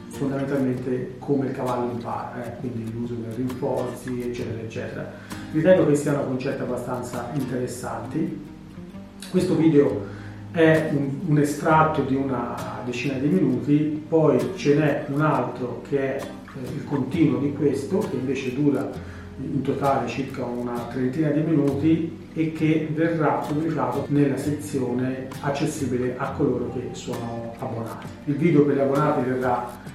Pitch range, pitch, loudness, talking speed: 125-150 Hz, 135 Hz, -24 LUFS, 135 wpm